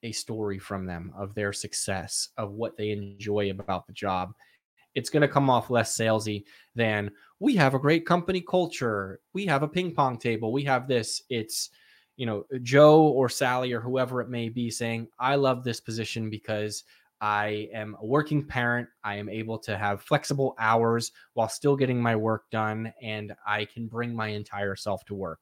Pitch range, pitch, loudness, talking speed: 105-130 Hz, 115 Hz, -27 LUFS, 190 wpm